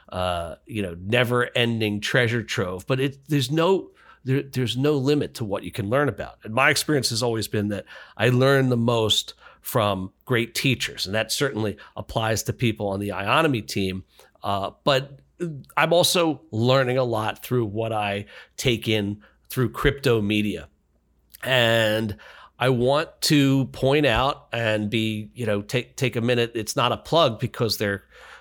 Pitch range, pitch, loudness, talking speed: 105-135 Hz, 120 Hz, -23 LUFS, 170 wpm